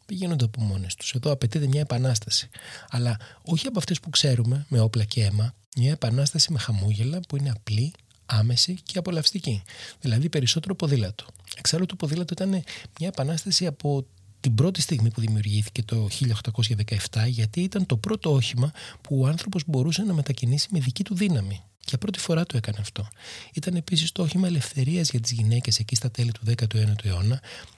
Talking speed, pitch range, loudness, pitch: 175 wpm, 115-160 Hz, -25 LUFS, 130 Hz